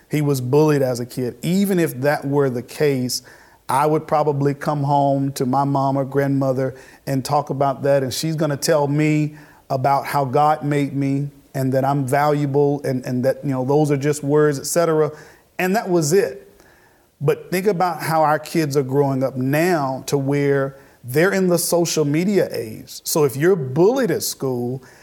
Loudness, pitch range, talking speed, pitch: -19 LUFS, 135-155 Hz, 190 wpm, 145 Hz